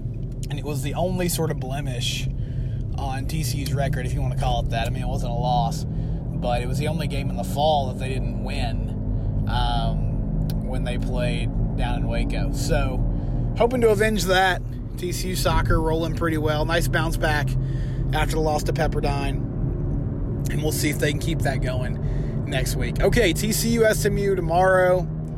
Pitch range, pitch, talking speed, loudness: 125-150 Hz, 135 Hz, 180 wpm, -24 LUFS